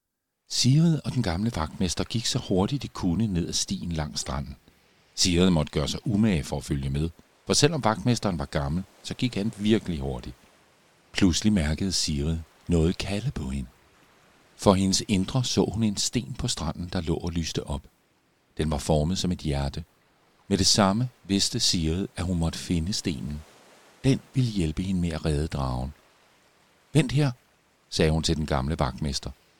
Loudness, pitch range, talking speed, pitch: -26 LUFS, 80-110 Hz, 175 wpm, 90 Hz